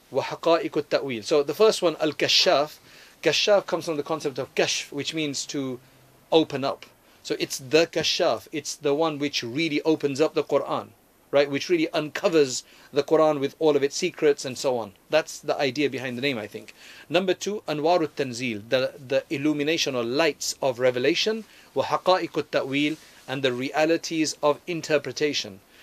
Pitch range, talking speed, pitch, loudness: 140-160 Hz, 165 wpm, 150 Hz, -24 LUFS